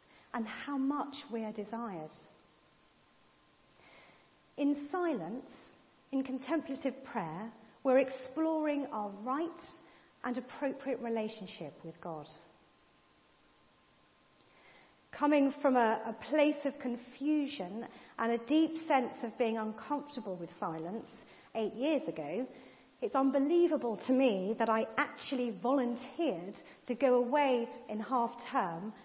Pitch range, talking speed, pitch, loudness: 220-280 Hz, 110 wpm, 250 Hz, -34 LUFS